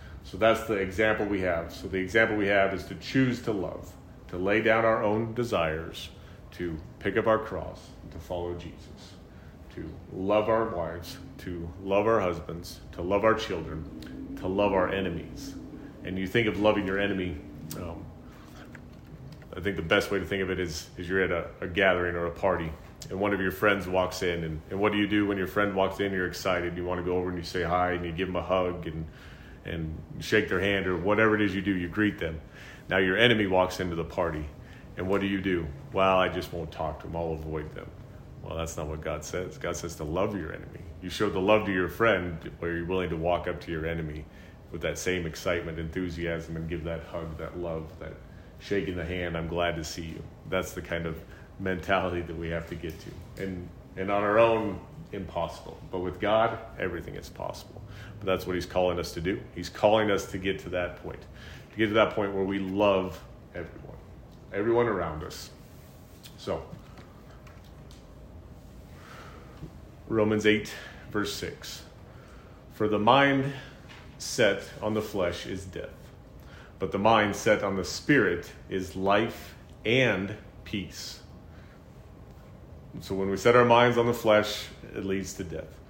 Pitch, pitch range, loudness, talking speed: 95 Hz, 85-105 Hz, -28 LUFS, 195 wpm